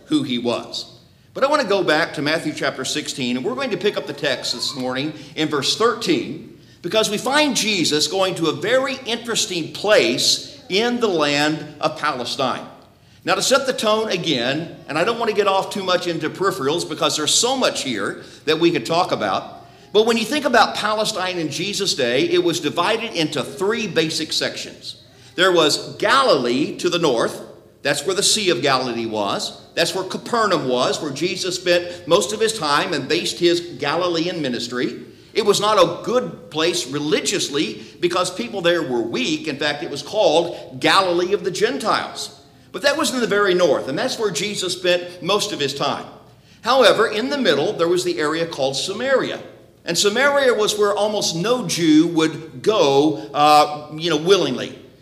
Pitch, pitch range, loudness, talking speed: 170 Hz, 150-205 Hz, -19 LUFS, 190 wpm